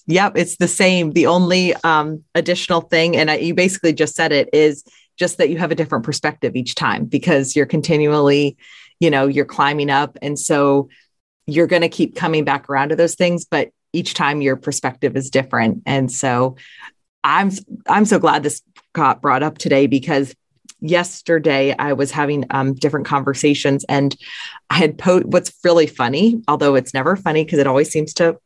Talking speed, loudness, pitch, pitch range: 185 wpm, -17 LUFS, 155 Hz, 140-170 Hz